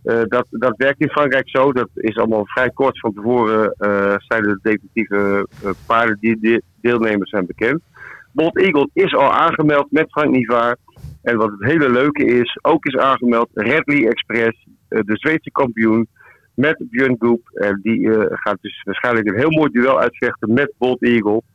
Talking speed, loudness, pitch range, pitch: 185 wpm, -17 LUFS, 110-135 Hz, 120 Hz